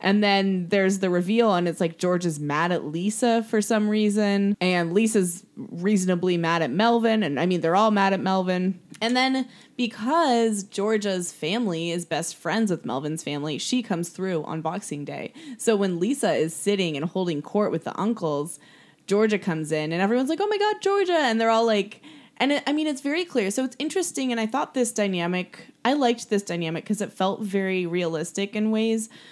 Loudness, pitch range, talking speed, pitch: -24 LUFS, 175-230 Hz, 200 wpm, 200 Hz